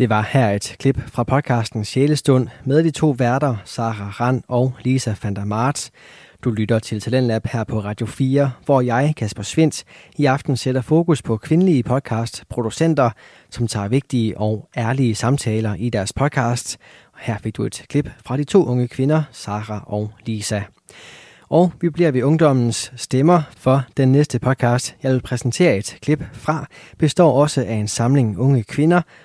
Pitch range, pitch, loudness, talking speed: 110-140 Hz, 125 Hz, -19 LUFS, 165 wpm